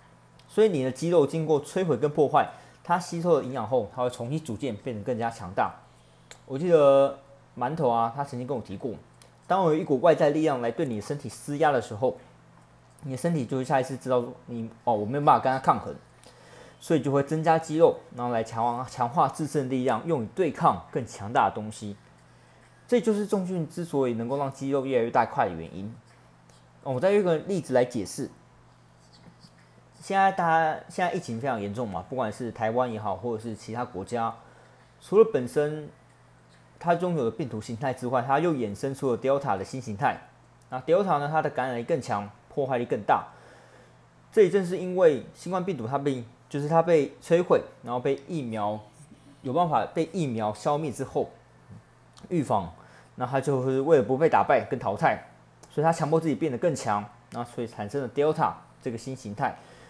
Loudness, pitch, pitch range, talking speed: -27 LUFS, 130 Hz, 110-155 Hz, 300 characters per minute